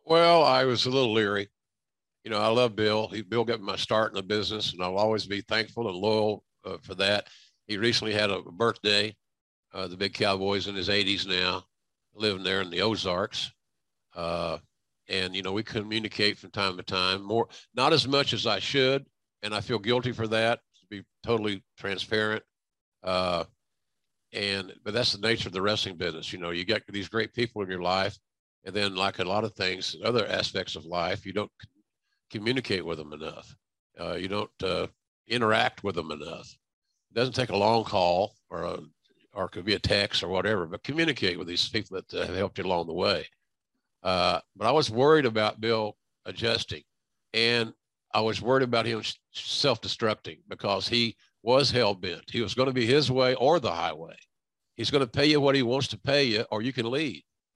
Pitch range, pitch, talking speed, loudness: 100-120 Hz, 110 Hz, 200 wpm, -27 LUFS